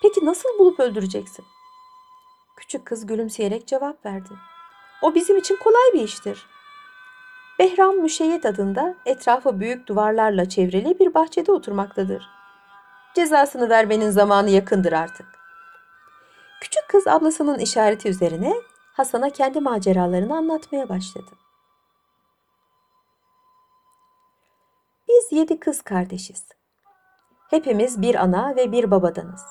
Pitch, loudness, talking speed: 260 Hz, -20 LUFS, 100 wpm